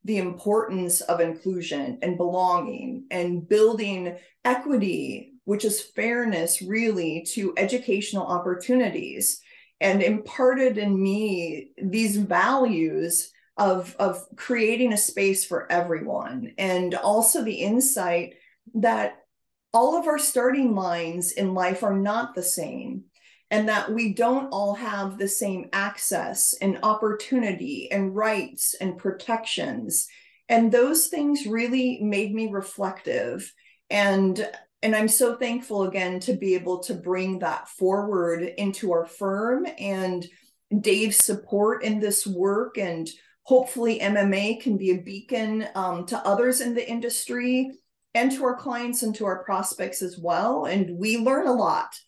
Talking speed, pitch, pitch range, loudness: 135 wpm, 205 Hz, 185-235 Hz, -24 LUFS